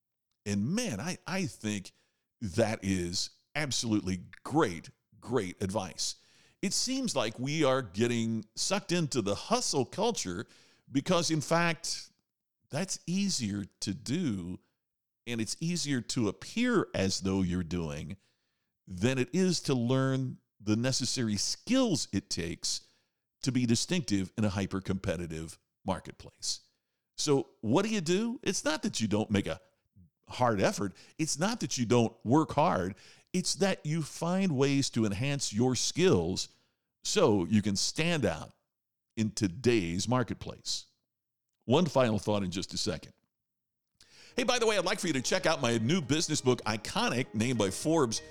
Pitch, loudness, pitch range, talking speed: 120 Hz, -31 LUFS, 100-155 Hz, 150 wpm